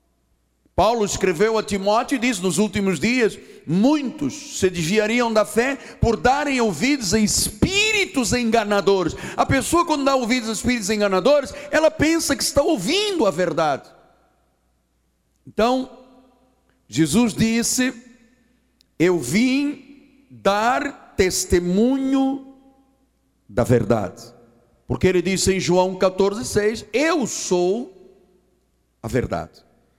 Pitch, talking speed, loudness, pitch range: 220 Hz, 110 wpm, -20 LUFS, 185-265 Hz